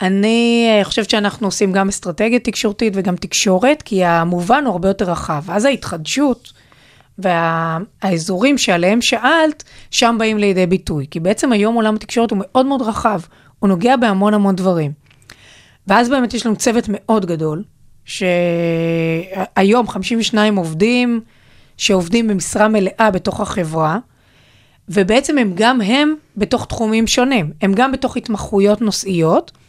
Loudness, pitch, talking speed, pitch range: -15 LUFS, 205 Hz, 130 wpm, 180-235 Hz